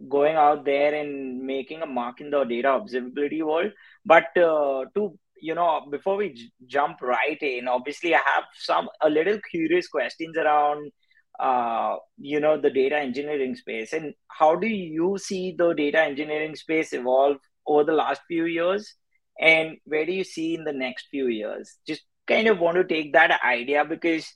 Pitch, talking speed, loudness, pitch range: 155 Hz, 180 wpm, -24 LUFS, 145-170 Hz